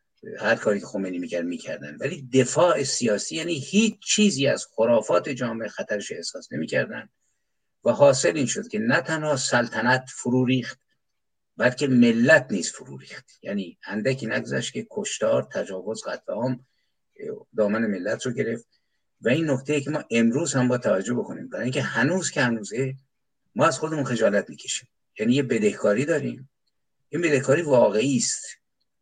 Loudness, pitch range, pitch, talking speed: -24 LUFS, 120-155 Hz, 130 Hz, 150 wpm